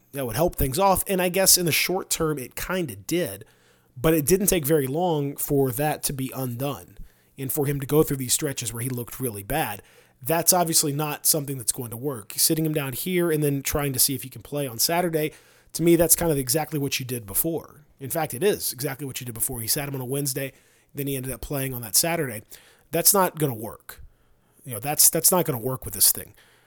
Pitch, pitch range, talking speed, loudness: 145 Hz, 130-160 Hz, 245 wpm, -23 LUFS